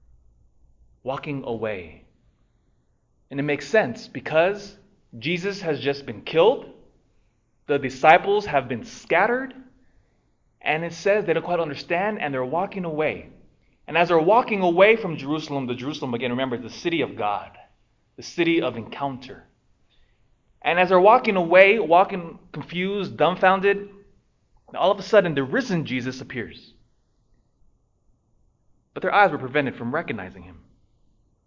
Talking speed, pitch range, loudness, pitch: 135 wpm, 125-195 Hz, -22 LUFS, 155 Hz